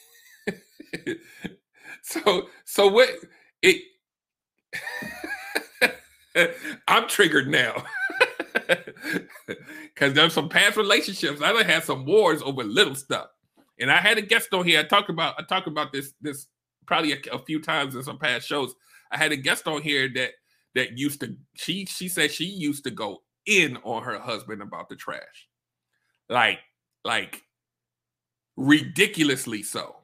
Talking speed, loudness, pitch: 140 wpm, -23 LUFS, 170 Hz